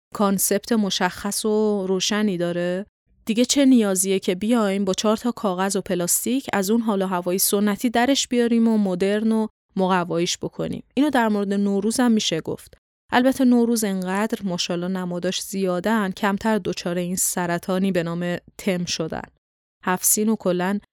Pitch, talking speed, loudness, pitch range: 200 Hz, 150 wpm, -21 LUFS, 185-220 Hz